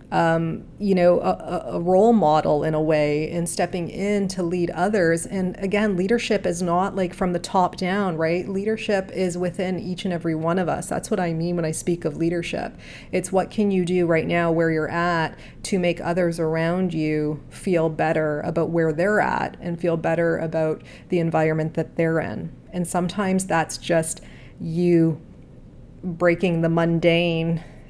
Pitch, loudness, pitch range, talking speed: 170 Hz, -22 LUFS, 165-185 Hz, 180 wpm